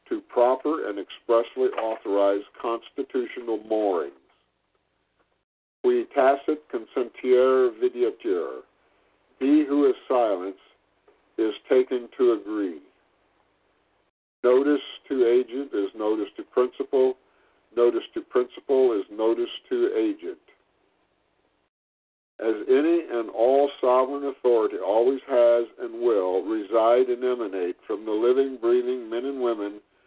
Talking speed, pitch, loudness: 105 wpm, 345 Hz, -24 LUFS